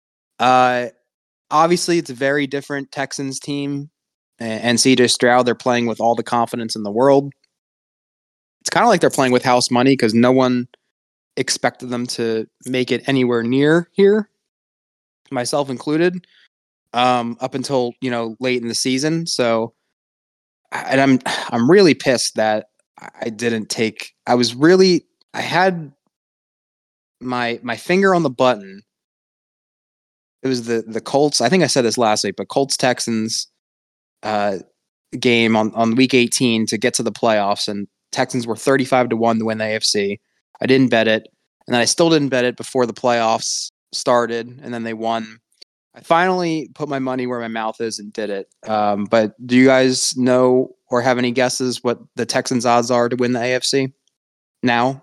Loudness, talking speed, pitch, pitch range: -18 LUFS, 175 wpm, 125 Hz, 115-135 Hz